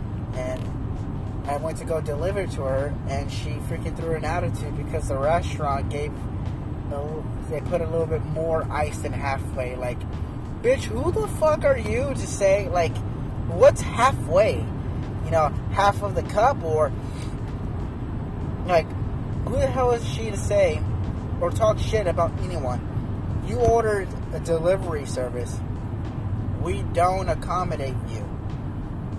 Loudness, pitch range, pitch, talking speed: -25 LUFS, 105-130 Hz, 110 Hz, 140 wpm